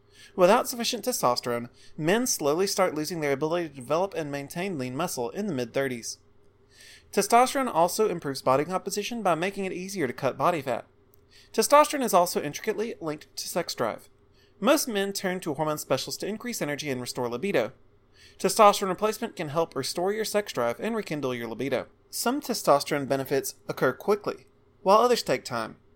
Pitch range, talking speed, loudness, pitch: 135-205 Hz, 170 wpm, -27 LUFS, 170 Hz